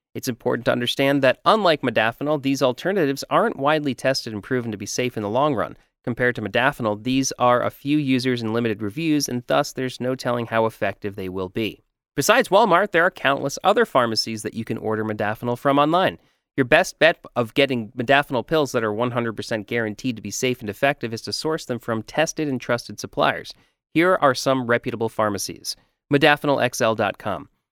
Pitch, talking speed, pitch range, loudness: 125 Hz, 190 wpm, 110-140 Hz, -21 LUFS